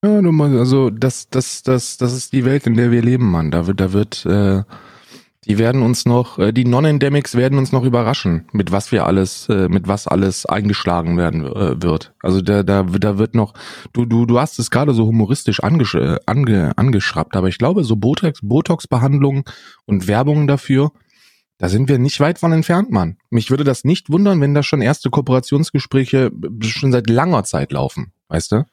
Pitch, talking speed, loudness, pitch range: 120 Hz, 200 wpm, -16 LUFS, 100-135 Hz